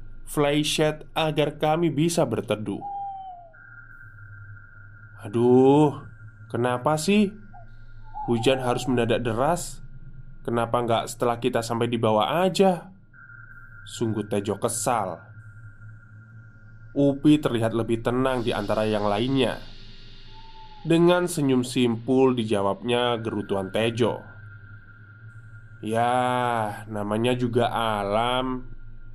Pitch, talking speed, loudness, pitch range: 120 Hz, 85 wpm, -24 LUFS, 110-130 Hz